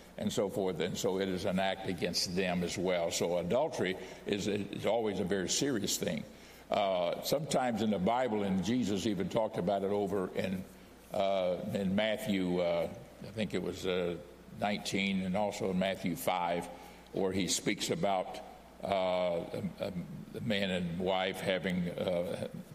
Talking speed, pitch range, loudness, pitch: 165 wpm, 90-100 Hz, -34 LUFS, 95 Hz